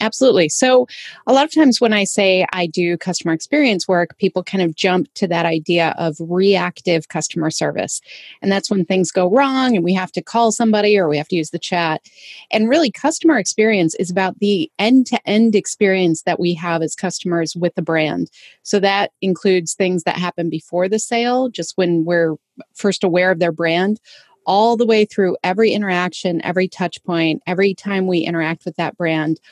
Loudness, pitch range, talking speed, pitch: -17 LUFS, 170-210 Hz, 195 wpm, 185 Hz